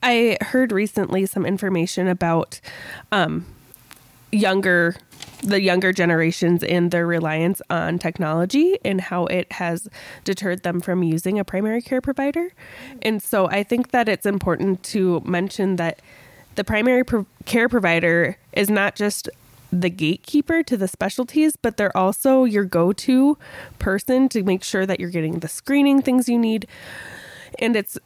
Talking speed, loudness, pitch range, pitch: 150 wpm, -20 LUFS, 175-235 Hz, 195 Hz